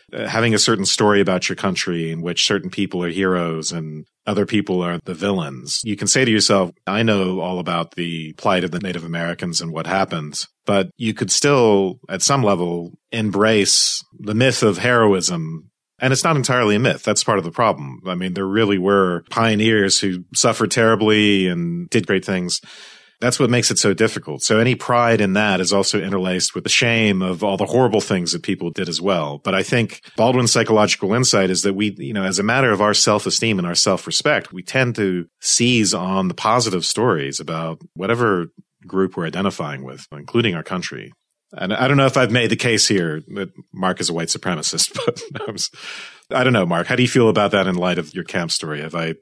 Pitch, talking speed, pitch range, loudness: 100 Hz, 210 wpm, 90-115 Hz, -18 LUFS